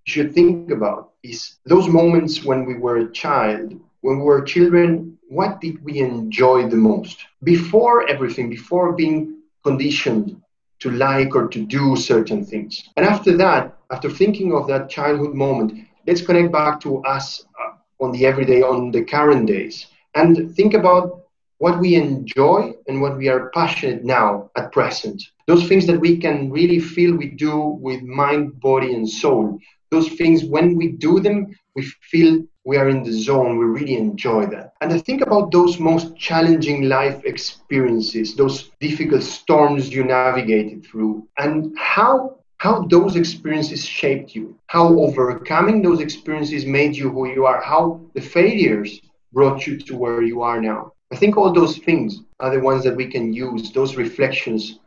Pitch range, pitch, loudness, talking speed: 130-170 Hz, 150 Hz, -17 LUFS, 170 wpm